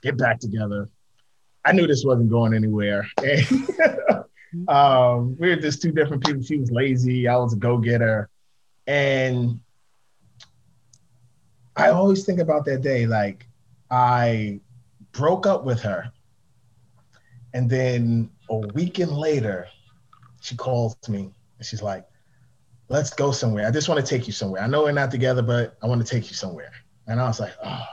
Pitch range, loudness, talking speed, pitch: 115-140 Hz, -22 LUFS, 160 wpm, 125 Hz